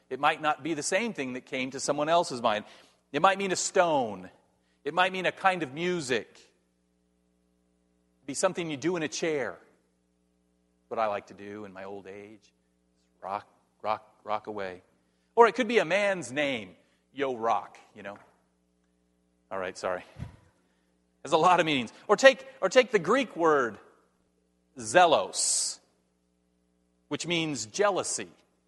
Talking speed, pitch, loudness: 160 wpm, 100 Hz, -27 LUFS